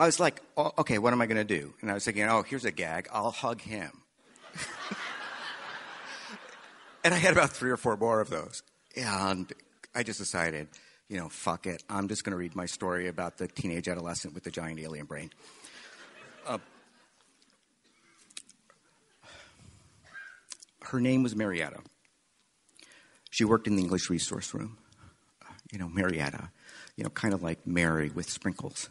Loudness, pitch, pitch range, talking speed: -31 LUFS, 95 Hz, 85-110 Hz, 160 wpm